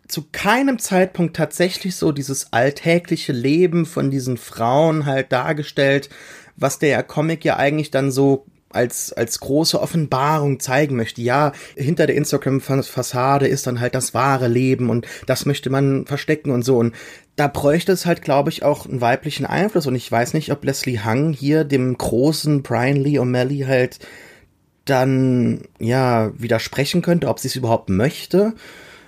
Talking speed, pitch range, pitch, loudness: 160 wpm, 125-155 Hz, 140 Hz, -19 LUFS